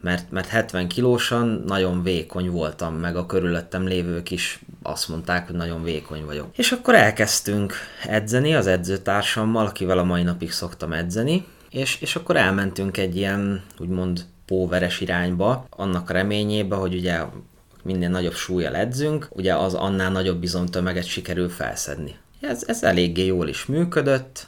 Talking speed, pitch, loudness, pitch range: 145 wpm, 95 Hz, -23 LUFS, 90-110 Hz